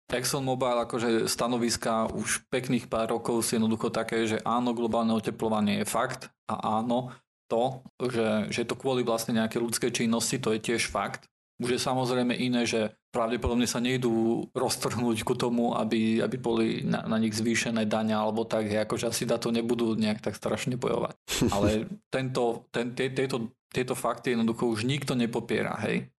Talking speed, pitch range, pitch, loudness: 160 wpm, 115-125 Hz, 120 Hz, -28 LUFS